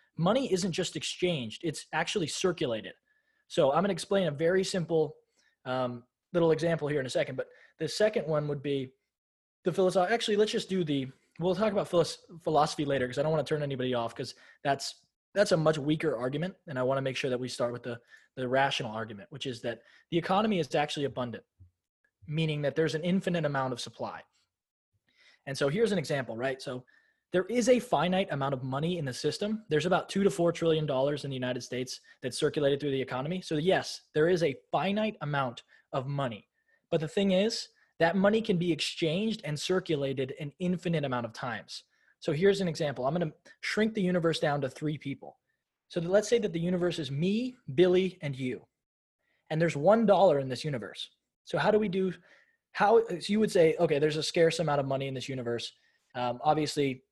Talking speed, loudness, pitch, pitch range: 205 wpm, -30 LUFS, 155 Hz, 135-185 Hz